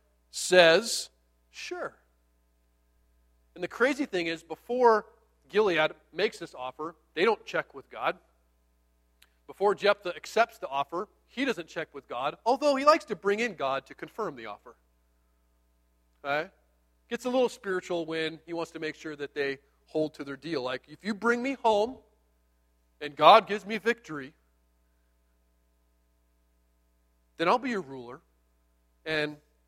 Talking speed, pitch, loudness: 145 wpm, 140 Hz, -28 LUFS